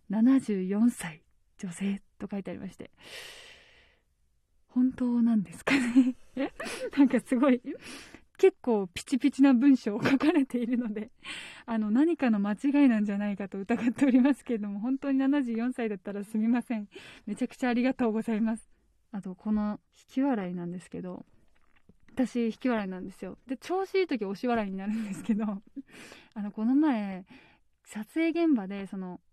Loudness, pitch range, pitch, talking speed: -28 LUFS, 210-270 Hz, 235 Hz, 315 characters per minute